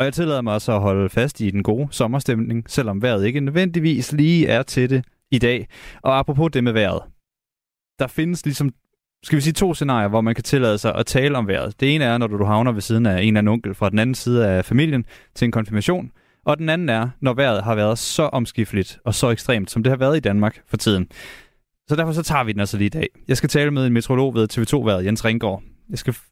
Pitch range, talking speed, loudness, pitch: 110-140 Hz, 250 wpm, -20 LUFS, 120 Hz